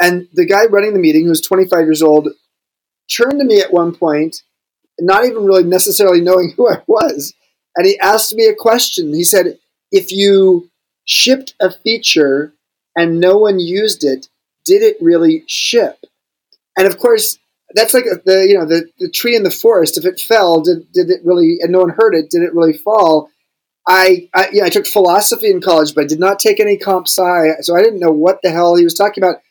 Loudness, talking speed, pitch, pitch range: -11 LUFS, 210 wpm, 190 Hz, 170-235 Hz